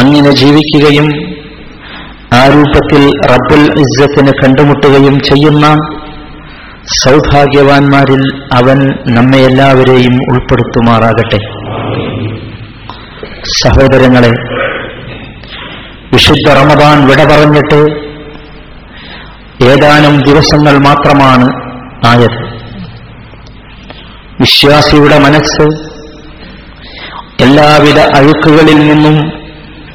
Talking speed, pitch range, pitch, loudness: 55 wpm, 130-150 Hz, 140 Hz, -5 LUFS